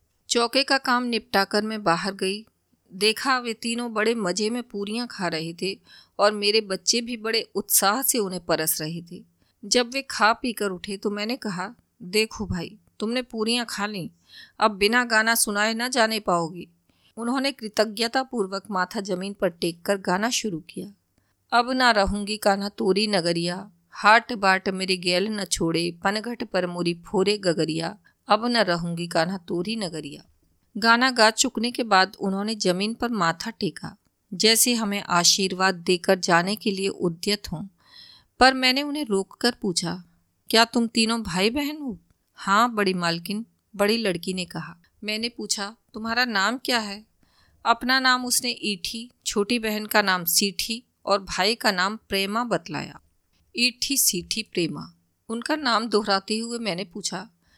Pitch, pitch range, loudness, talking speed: 205 Hz, 185-230 Hz, -23 LUFS, 155 wpm